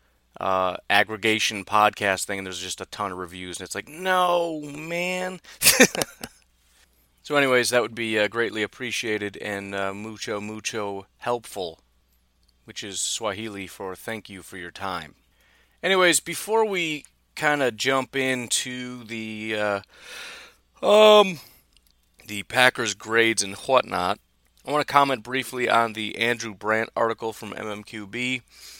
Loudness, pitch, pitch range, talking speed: -23 LUFS, 110 Hz, 95-130 Hz, 135 wpm